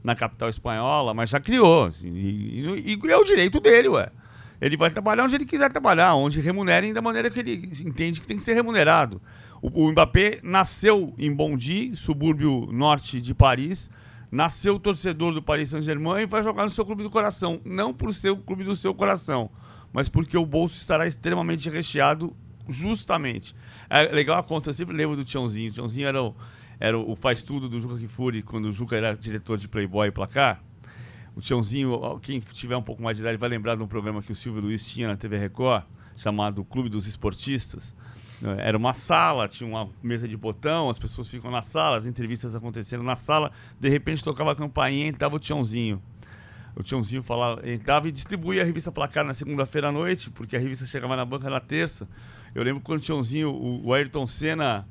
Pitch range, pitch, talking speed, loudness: 115-160 Hz, 130 Hz, 200 wpm, -24 LUFS